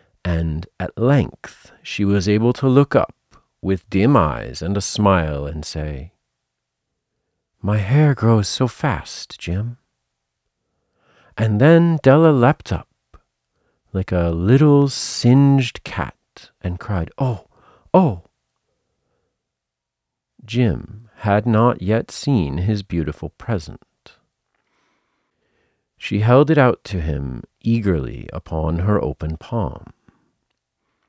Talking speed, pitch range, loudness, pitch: 110 wpm, 85-125 Hz, -18 LUFS, 105 Hz